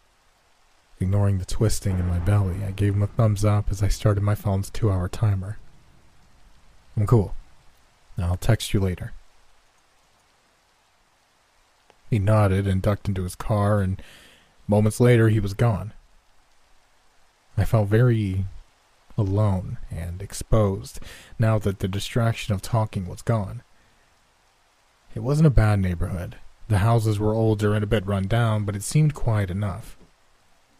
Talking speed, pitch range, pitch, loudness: 140 wpm, 95-110 Hz, 105 Hz, -23 LUFS